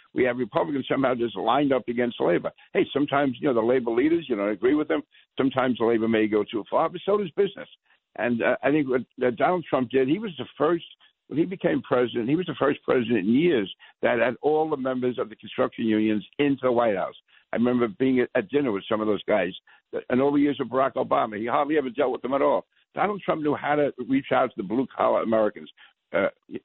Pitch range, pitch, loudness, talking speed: 120-145 Hz, 130 Hz, -25 LUFS, 245 wpm